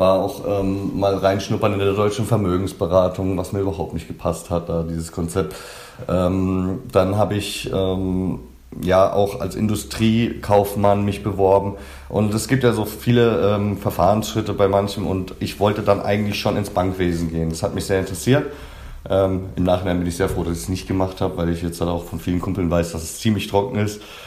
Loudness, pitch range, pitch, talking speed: -20 LUFS, 90-105 Hz, 95 Hz, 200 wpm